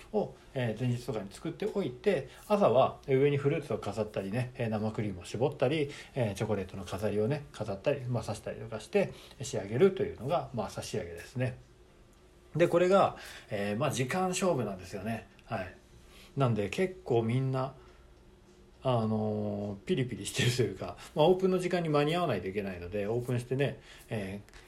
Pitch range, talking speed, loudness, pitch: 105-145 Hz, 360 characters per minute, -32 LUFS, 125 Hz